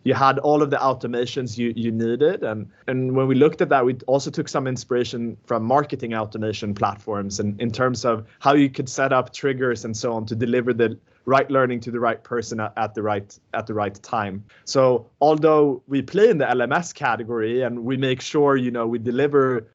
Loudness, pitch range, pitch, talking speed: -22 LUFS, 115-135 Hz, 125 Hz, 215 wpm